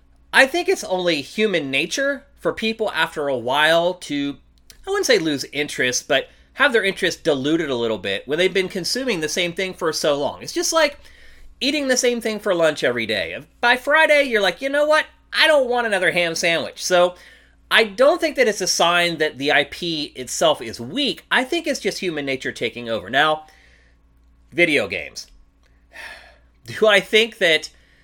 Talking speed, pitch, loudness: 190 wpm, 185 Hz, -19 LUFS